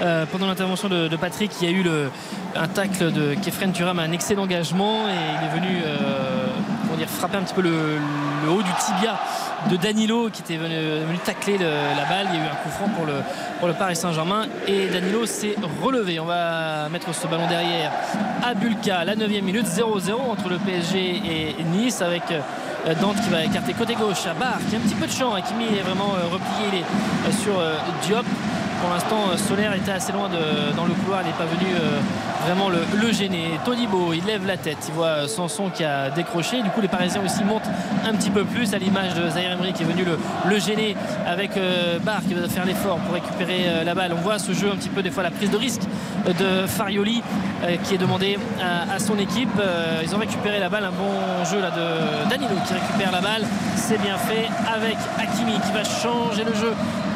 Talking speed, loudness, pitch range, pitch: 225 wpm, -23 LUFS, 175-215 Hz, 195 Hz